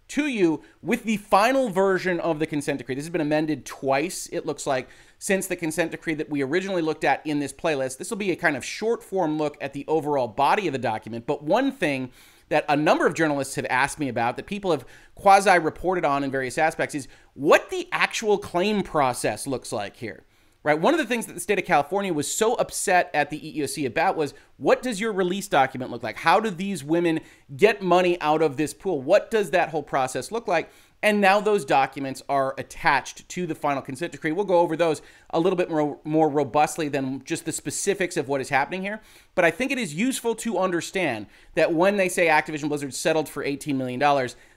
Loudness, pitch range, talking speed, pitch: -24 LUFS, 140-190 Hz, 225 wpm, 160 Hz